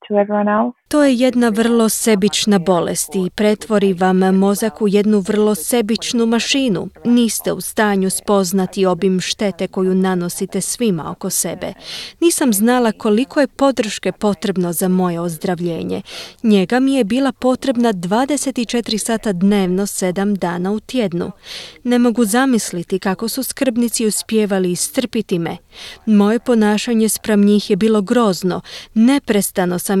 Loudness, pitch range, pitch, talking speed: -16 LUFS, 190-240 Hz, 210 Hz, 130 wpm